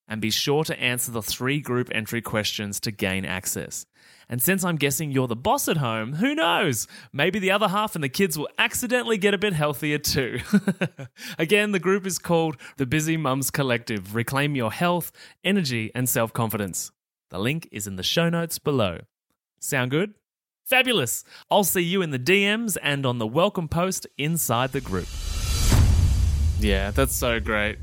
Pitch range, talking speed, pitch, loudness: 110-180 Hz, 180 wpm, 140 Hz, -24 LUFS